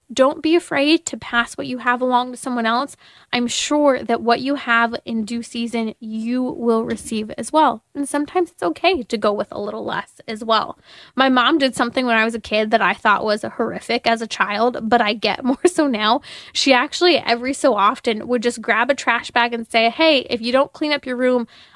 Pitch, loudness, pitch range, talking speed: 245 Hz, -19 LUFS, 230-275 Hz, 225 wpm